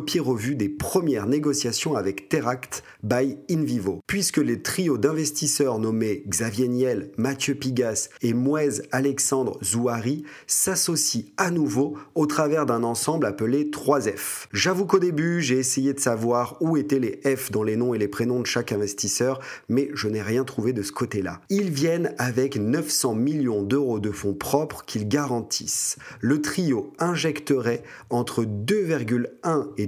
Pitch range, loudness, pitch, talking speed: 115-150 Hz, -24 LUFS, 130 Hz, 150 wpm